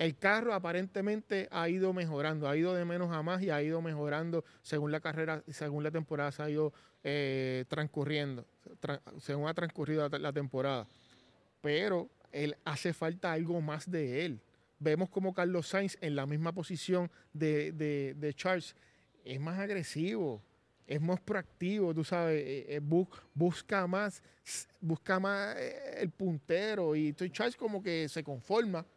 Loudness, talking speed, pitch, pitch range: -35 LUFS, 155 wpm, 160 Hz, 150-180 Hz